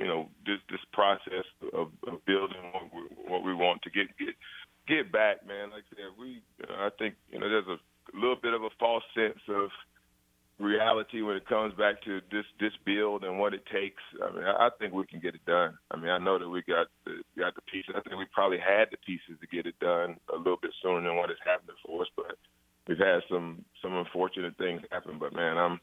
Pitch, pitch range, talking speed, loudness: 95 Hz, 90-110 Hz, 240 wpm, -31 LUFS